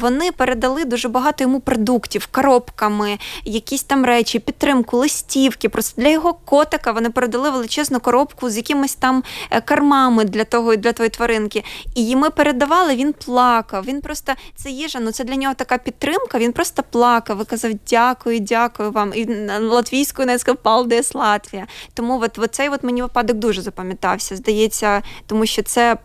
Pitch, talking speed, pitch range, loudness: 245 Hz, 165 wpm, 225-270 Hz, -18 LUFS